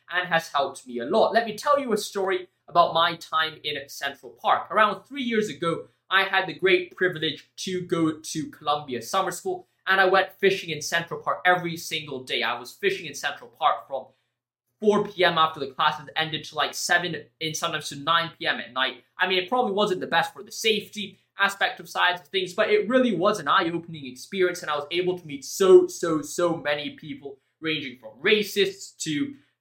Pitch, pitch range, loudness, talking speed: 175 Hz, 155-195 Hz, -24 LUFS, 210 wpm